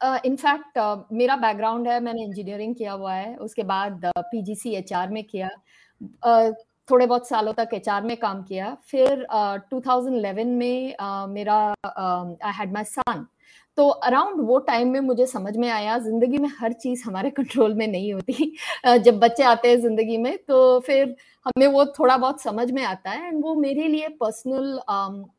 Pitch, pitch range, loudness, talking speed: 235 Hz, 210-260 Hz, -22 LUFS, 170 wpm